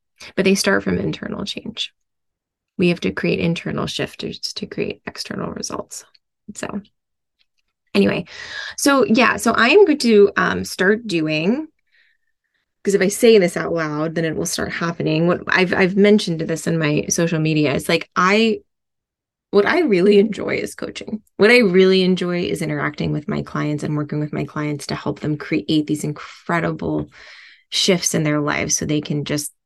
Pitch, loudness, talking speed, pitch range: 185 Hz, -18 LUFS, 175 wpm, 155-210 Hz